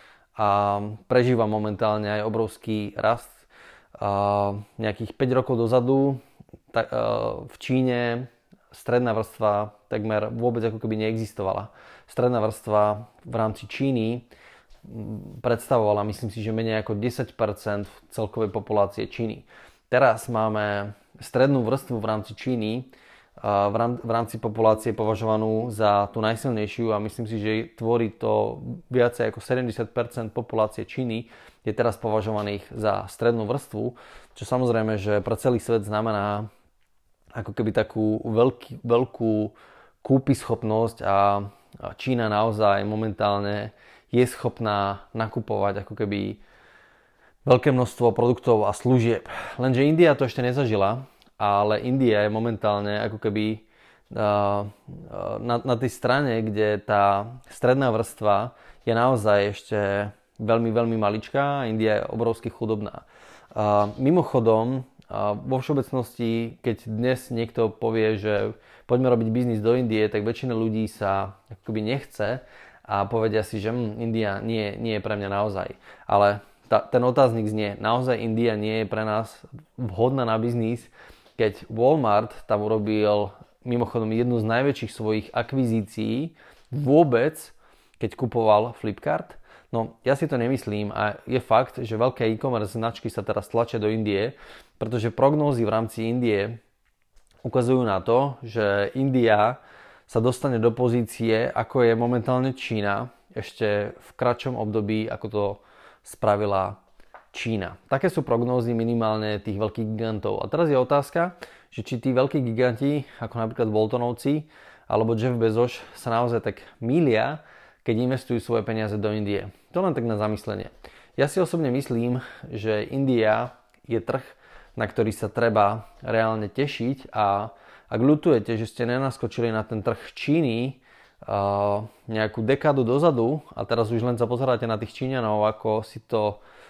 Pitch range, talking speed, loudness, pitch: 105-125 Hz, 135 wpm, -24 LUFS, 115 Hz